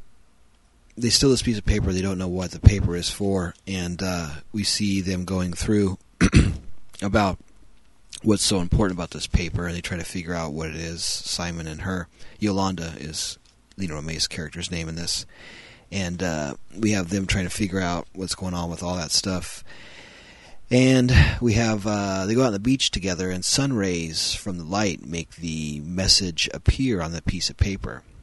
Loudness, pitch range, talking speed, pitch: -24 LUFS, 85-100 Hz, 190 wpm, 95 Hz